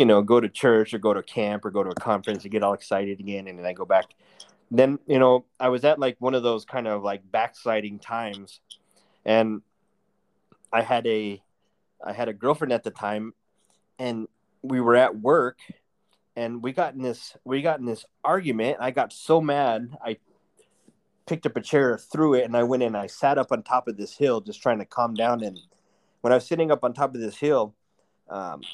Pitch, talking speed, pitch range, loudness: 120 Hz, 220 wpm, 105-125 Hz, -24 LUFS